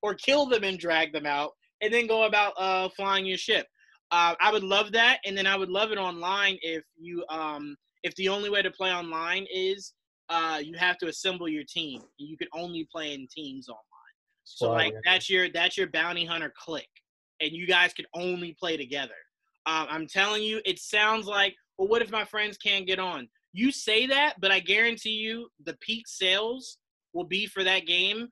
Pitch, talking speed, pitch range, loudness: 190 Hz, 210 wpm, 170-210 Hz, -26 LUFS